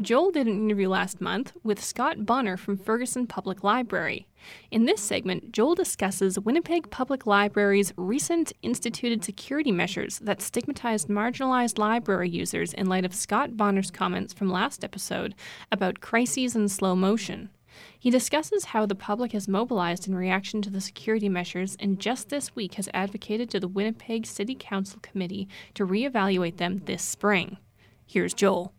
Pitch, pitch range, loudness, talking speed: 205 Hz, 195-235 Hz, -27 LUFS, 160 wpm